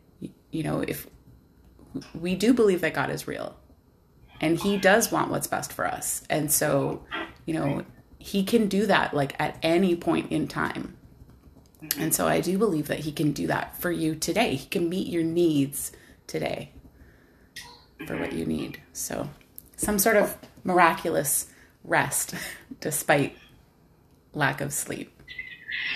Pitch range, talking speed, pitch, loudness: 145-195 Hz, 150 wpm, 170 Hz, -26 LUFS